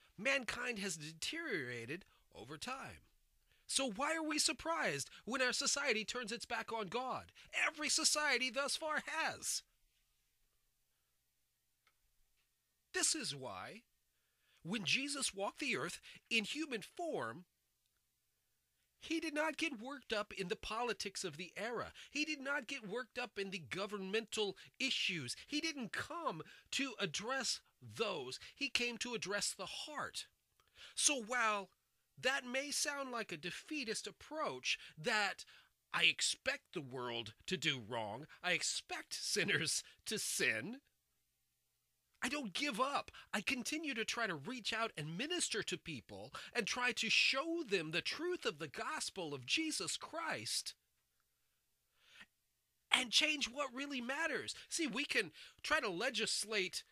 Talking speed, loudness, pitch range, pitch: 135 wpm, -39 LUFS, 205-290 Hz, 250 Hz